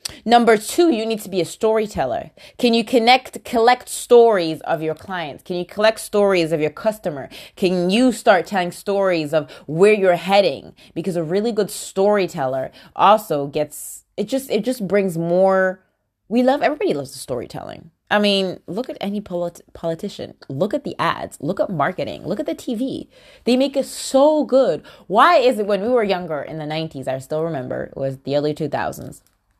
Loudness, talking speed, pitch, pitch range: -19 LUFS, 185 wpm, 195 Hz, 165-230 Hz